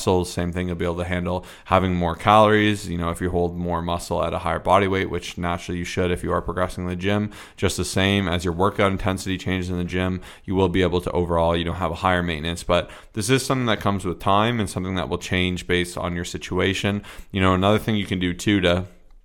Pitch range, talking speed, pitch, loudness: 85-95 Hz, 260 wpm, 90 Hz, -22 LUFS